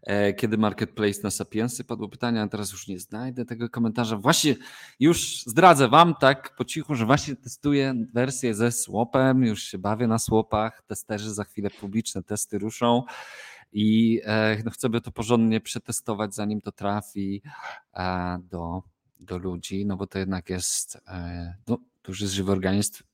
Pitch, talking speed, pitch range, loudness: 110 Hz, 155 wpm, 100-120 Hz, -25 LUFS